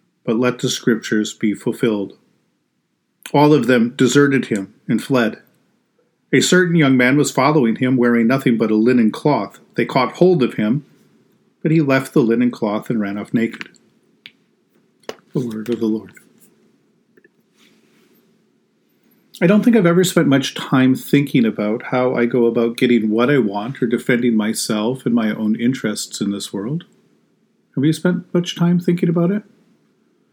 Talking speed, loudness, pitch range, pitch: 160 wpm, -17 LUFS, 115-160 Hz, 125 Hz